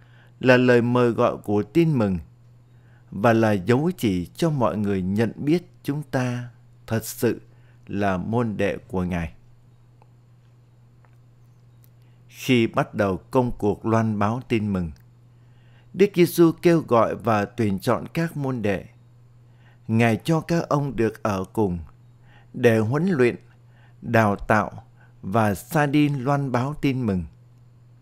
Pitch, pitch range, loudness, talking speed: 120 Hz, 110-125 Hz, -22 LUFS, 135 wpm